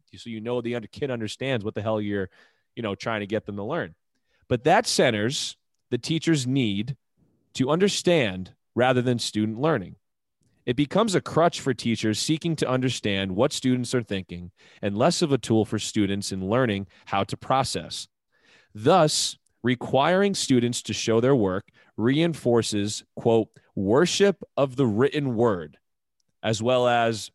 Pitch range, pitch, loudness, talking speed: 105-140 Hz, 120 Hz, -24 LUFS, 160 wpm